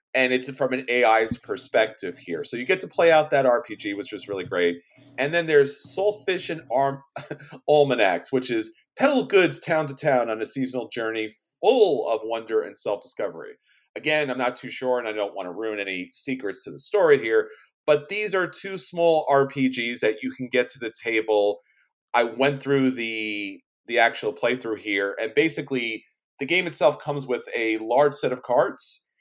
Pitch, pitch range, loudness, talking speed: 130 Hz, 115-155 Hz, -24 LUFS, 190 wpm